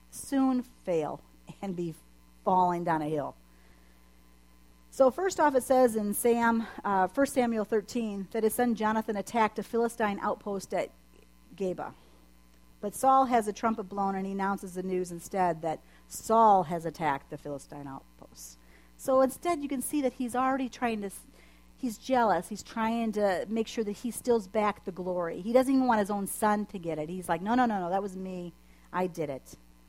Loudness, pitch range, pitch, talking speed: -29 LUFS, 160-230 Hz, 200 Hz, 185 wpm